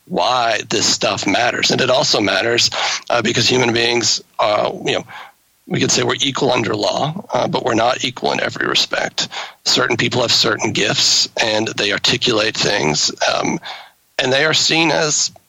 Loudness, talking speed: -15 LUFS, 175 wpm